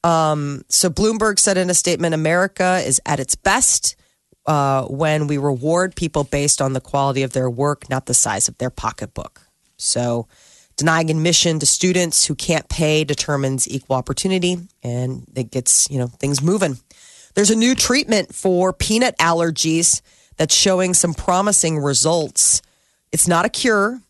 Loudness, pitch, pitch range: -17 LUFS, 160 Hz, 140-185 Hz